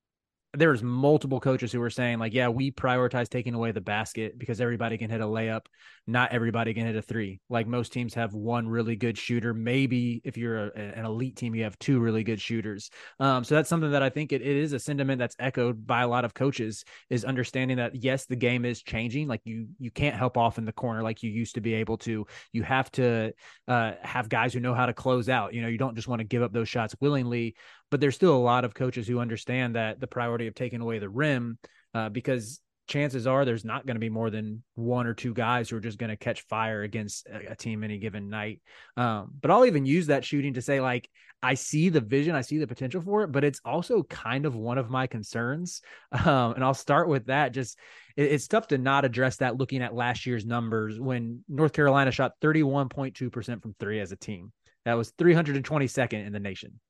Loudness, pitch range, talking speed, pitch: -28 LUFS, 115-135 Hz, 235 wpm, 120 Hz